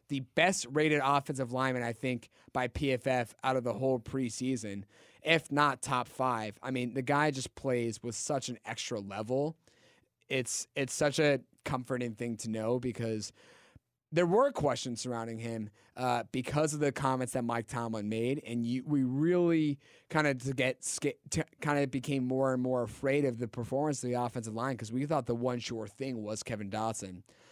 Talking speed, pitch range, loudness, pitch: 185 wpm, 115-140 Hz, -33 LUFS, 130 Hz